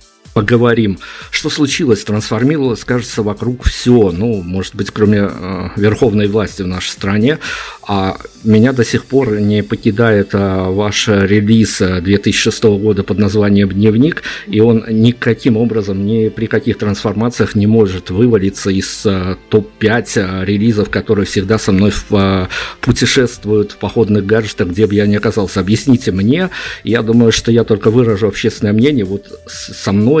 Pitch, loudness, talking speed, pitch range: 105 Hz, -13 LUFS, 140 wpm, 100-115 Hz